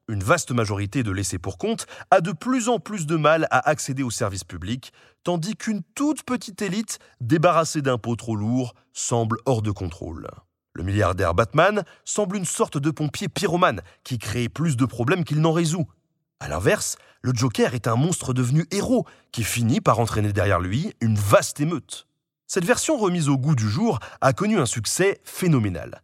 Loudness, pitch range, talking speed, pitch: -23 LUFS, 115-180 Hz, 180 wpm, 140 Hz